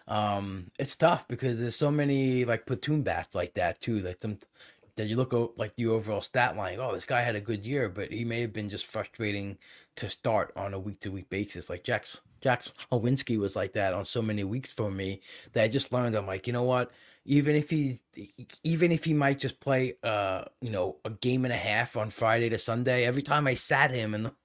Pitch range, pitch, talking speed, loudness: 105-130 Hz, 120 Hz, 230 wpm, -30 LUFS